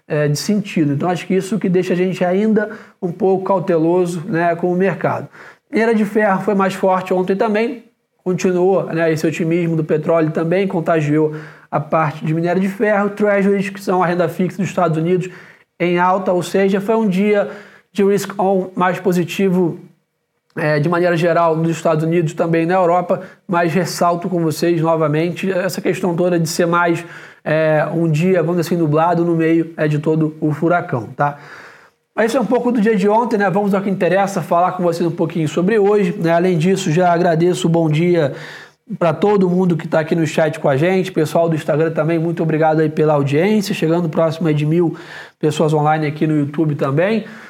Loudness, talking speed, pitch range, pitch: -16 LUFS, 195 wpm, 165-190 Hz, 175 Hz